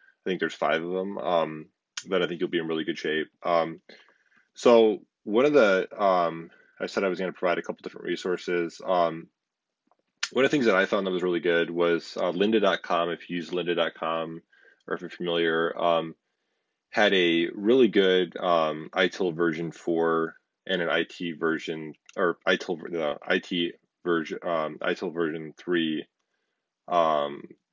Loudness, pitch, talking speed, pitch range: -26 LUFS, 85 Hz, 175 wpm, 80-85 Hz